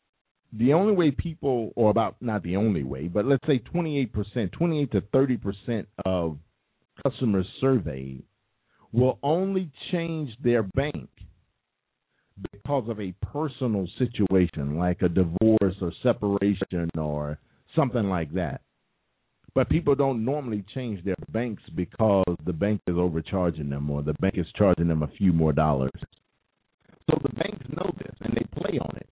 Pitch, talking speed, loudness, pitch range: 105 Hz, 150 wpm, -26 LUFS, 90-130 Hz